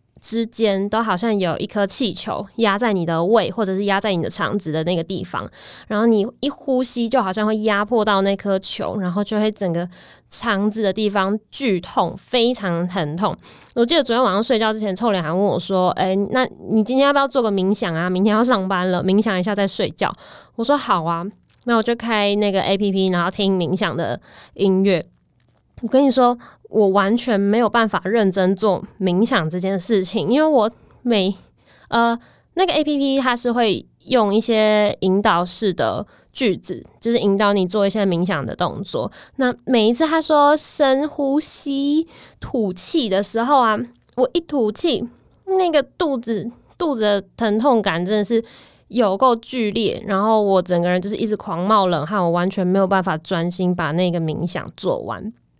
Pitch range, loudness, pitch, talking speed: 190-235 Hz, -19 LUFS, 210 Hz, 270 characters per minute